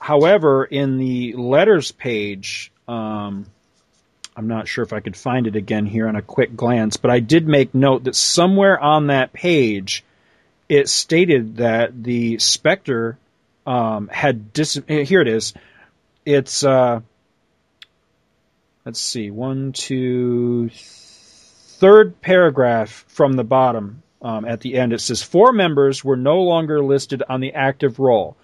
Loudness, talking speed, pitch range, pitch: -17 LUFS, 145 wpm, 110-140 Hz, 125 Hz